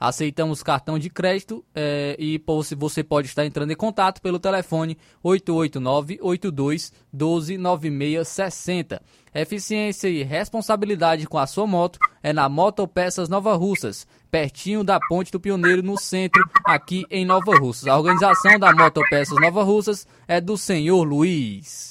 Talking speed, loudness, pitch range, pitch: 135 wpm, -20 LUFS, 155-195 Hz, 175 Hz